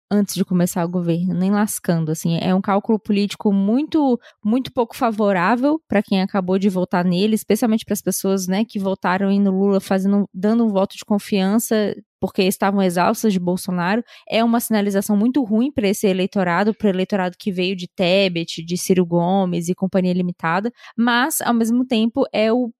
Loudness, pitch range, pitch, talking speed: -19 LUFS, 185-225 Hz, 200 Hz, 180 wpm